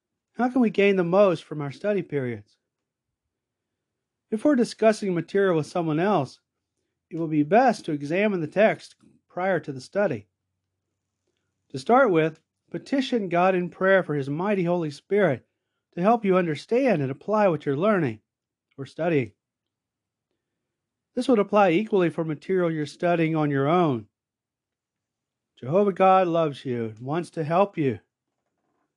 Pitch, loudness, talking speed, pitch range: 165 Hz, -24 LUFS, 150 wpm, 135-200 Hz